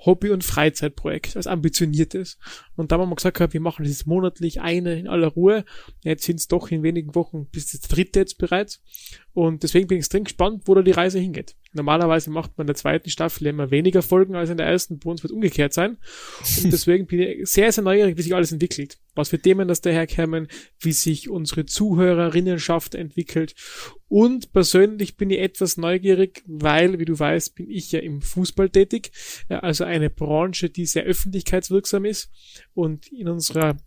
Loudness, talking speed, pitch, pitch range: -21 LUFS, 190 wpm, 175 Hz, 160-185 Hz